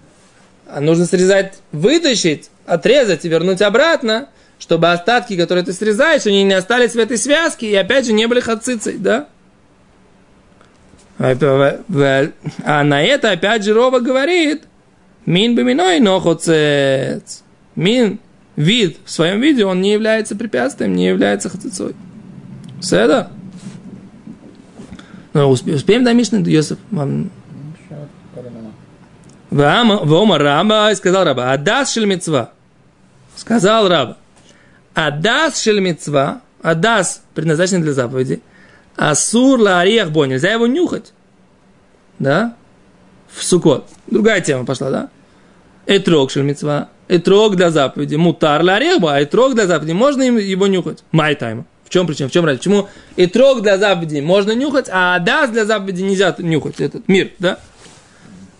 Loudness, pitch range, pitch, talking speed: -14 LUFS, 155-220 Hz, 190 Hz, 125 wpm